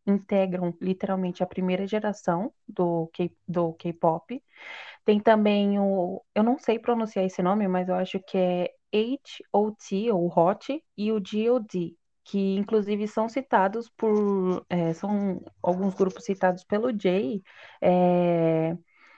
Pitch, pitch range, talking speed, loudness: 195 Hz, 180-220 Hz, 130 wpm, -26 LUFS